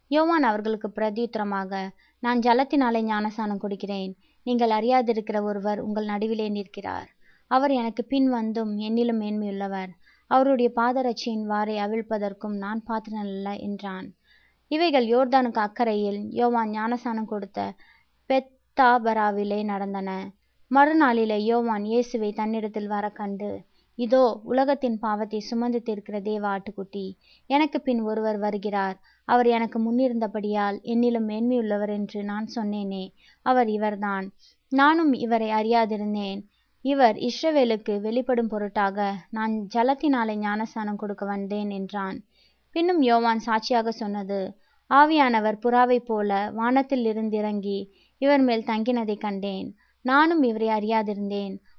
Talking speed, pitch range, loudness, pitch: 105 wpm, 205-240 Hz, -25 LUFS, 220 Hz